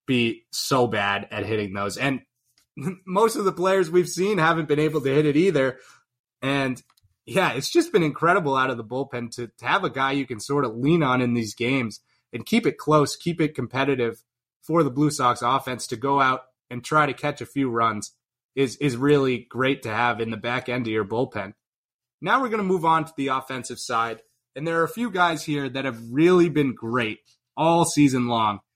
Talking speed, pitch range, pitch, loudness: 215 wpm, 120-150 Hz, 130 Hz, -23 LUFS